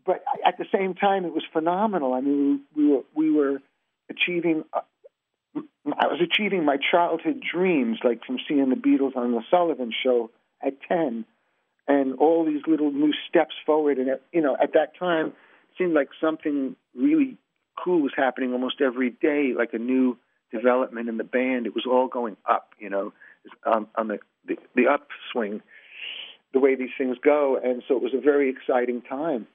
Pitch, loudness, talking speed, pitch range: 145 Hz, -24 LUFS, 185 wpm, 125-170 Hz